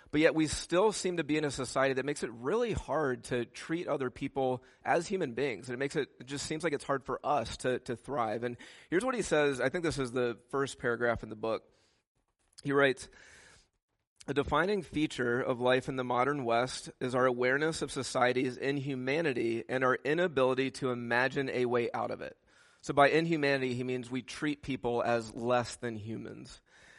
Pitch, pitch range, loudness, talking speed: 130 Hz, 125-145 Hz, -32 LUFS, 200 wpm